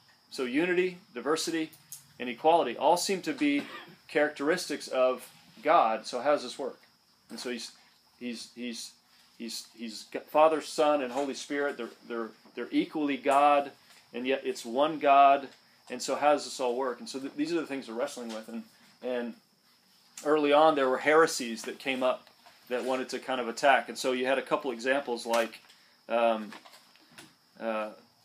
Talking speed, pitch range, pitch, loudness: 175 wpm, 120-150 Hz, 135 Hz, -29 LUFS